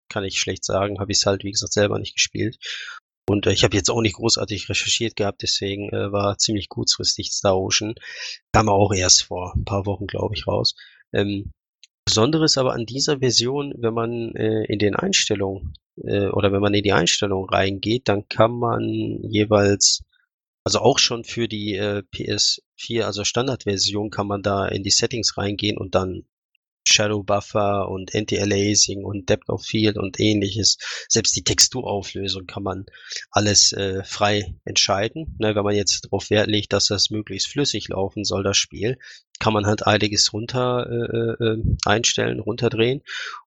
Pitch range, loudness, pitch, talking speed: 100-110 Hz, -20 LUFS, 105 Hz, 170 wpm